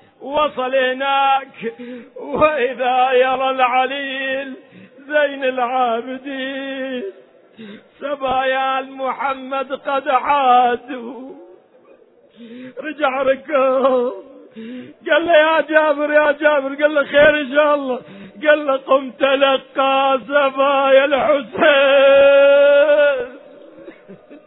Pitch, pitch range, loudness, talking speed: 270 Hz, 260-285 Hz, -16 LUFS, 75 wpm